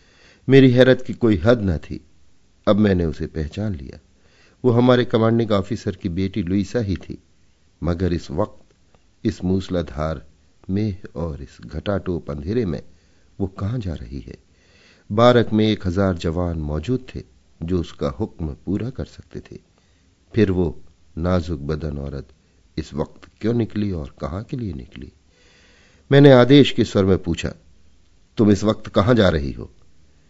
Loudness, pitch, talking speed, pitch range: -20 LUFS, 90 Hz, 155 wpm, 80-105 Hz